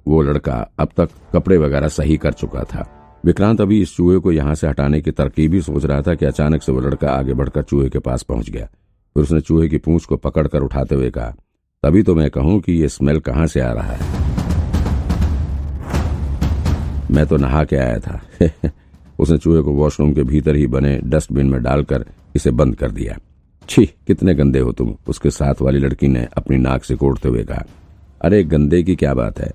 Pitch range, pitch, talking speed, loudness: 70-80 Hz, 75 Hz, 205 wpm, -17 LUFS